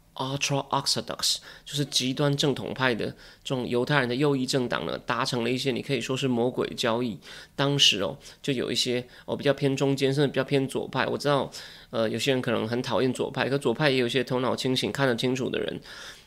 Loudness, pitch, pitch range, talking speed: -26 LUFS, 130 Hz, 125-140 Hz, 345 characters per minute